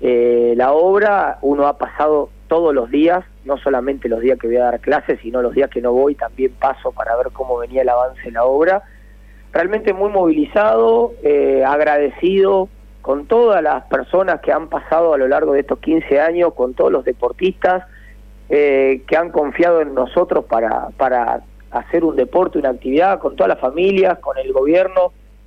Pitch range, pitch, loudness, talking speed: 125-180 Hz, 145 Hz, -16 LUFS, 185 wpm